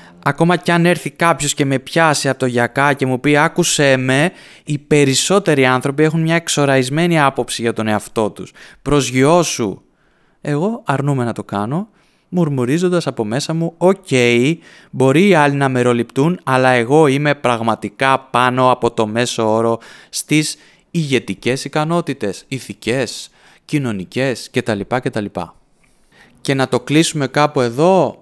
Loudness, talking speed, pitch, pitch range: -16 LUFS, 140 wpm, 135 Hz, 120-155 Hz